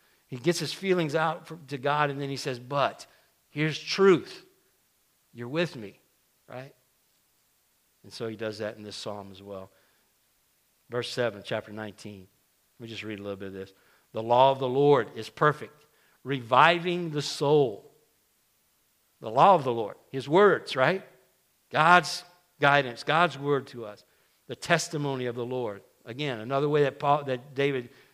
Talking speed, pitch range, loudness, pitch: 165 wpm, 110-150 Hz, -26 LUFS, 135 Hz